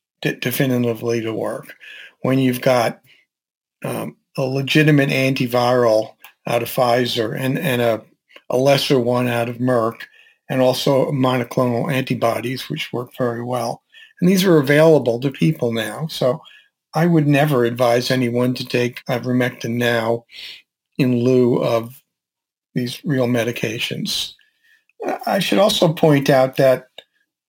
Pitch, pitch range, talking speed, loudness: 130 Hz, 120-145 Hz, 130 wpm, -18 LUFS